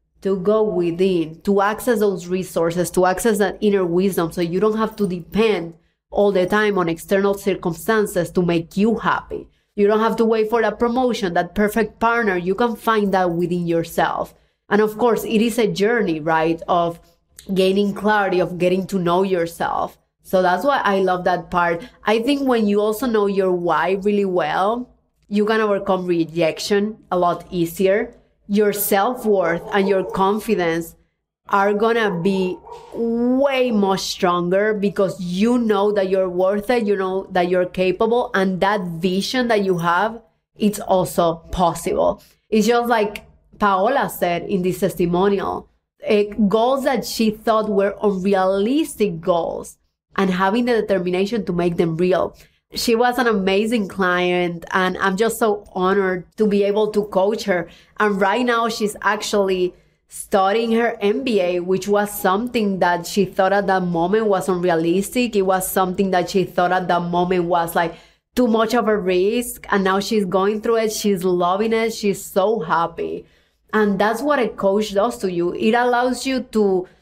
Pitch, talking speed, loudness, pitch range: 200 Hz, 170 wpm, -19 LUFS, 185-220 Hz